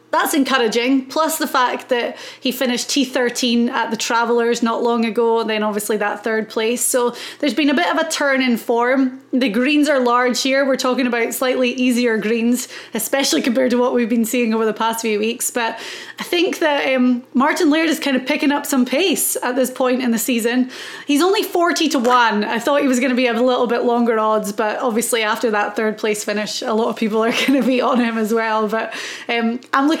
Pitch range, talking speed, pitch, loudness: 230-270 Hz, 230 wpm, 245 Hz, -17 LUFS